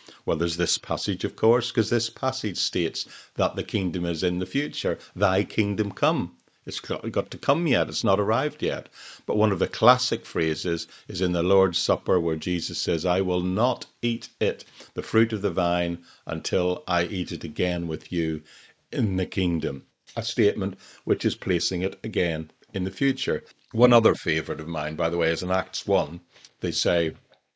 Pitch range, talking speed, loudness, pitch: 85-110 Hz, 190 wpm, -25 LUFS, 90 Hz